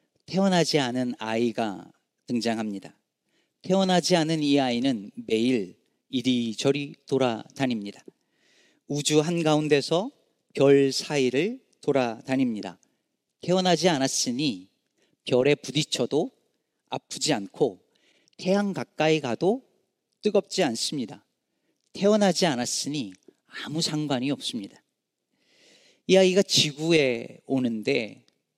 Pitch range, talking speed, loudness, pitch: 125-180 Hz, 235 characters per minute, -25 LUFS, 145 Hz